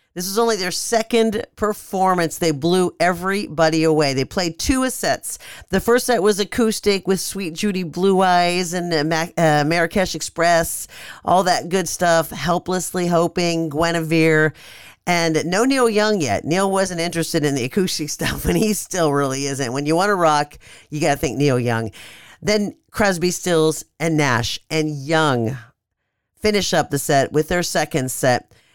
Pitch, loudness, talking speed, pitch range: 170 Hz, -19 LUFS, 165 wpm, 150-190 Hz